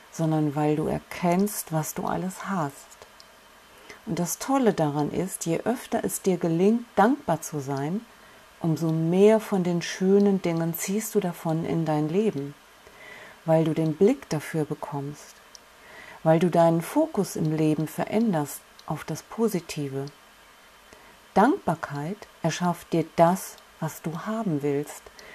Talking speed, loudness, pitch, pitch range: 135 wpm, -26 LUFS, 170 Hz, 155-200 Hz